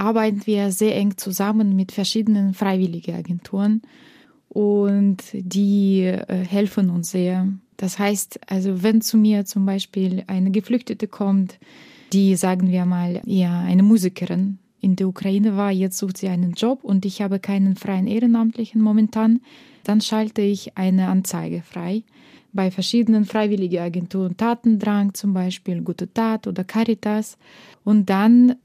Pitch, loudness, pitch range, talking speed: 200 Hz, -20 LUFS, 190-220 Hz, 140 wpm